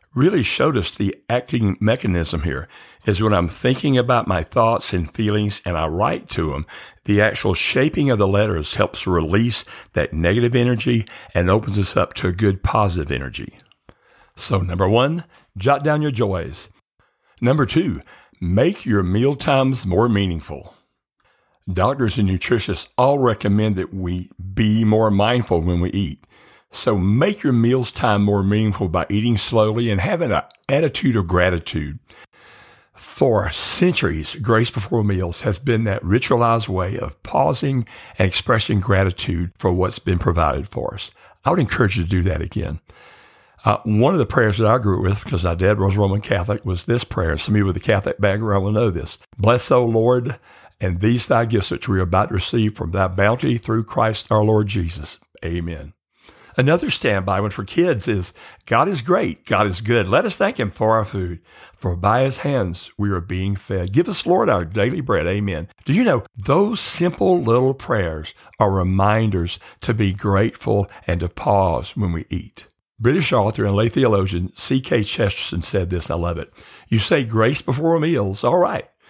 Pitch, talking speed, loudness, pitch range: 100 Hz, 180 wpm, -19 LUFS, 90-115 Hz